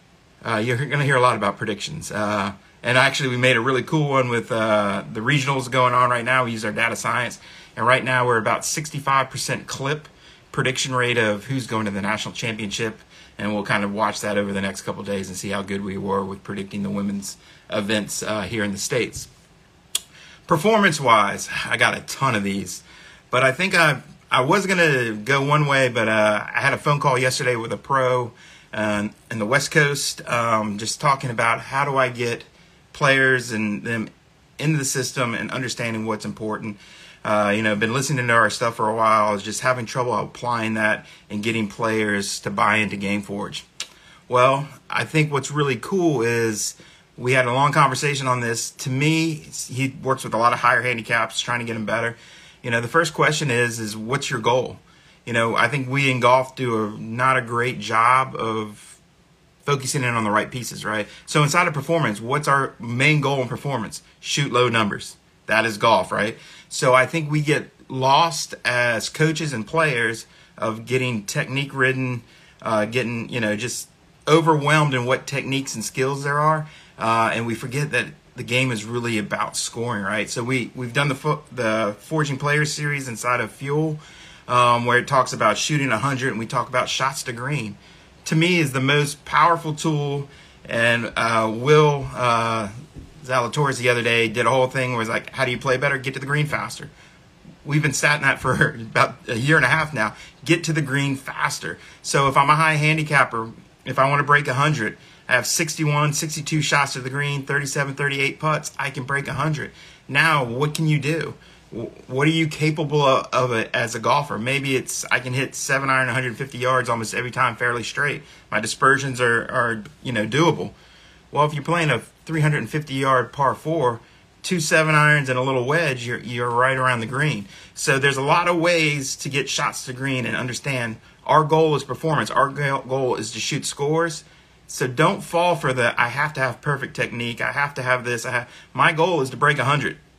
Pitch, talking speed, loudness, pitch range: 130 Hz, 205 wpm, -21 LUFS, 115-150 Hz